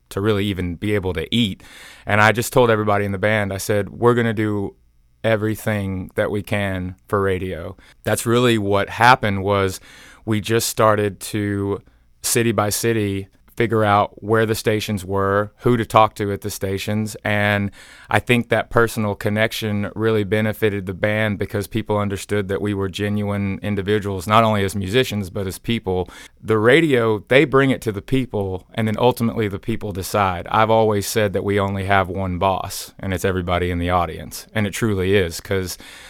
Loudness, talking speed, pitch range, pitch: -20 LUFS, 185 wpm, 95-110 Hz, 105 Hz